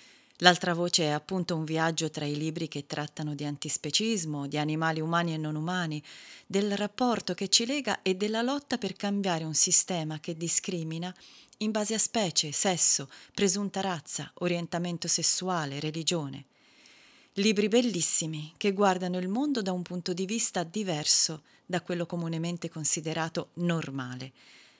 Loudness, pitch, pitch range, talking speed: -27 LUFS, 175 Hz, 155-195 Hz, 145 wpm